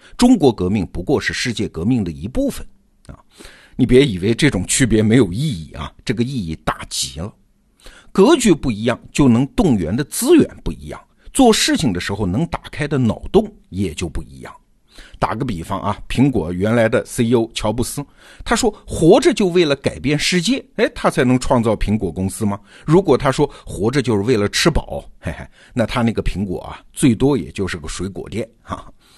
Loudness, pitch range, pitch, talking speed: -17 LUFS, 100-145 Hz, 120 Hz, 280 characters per minute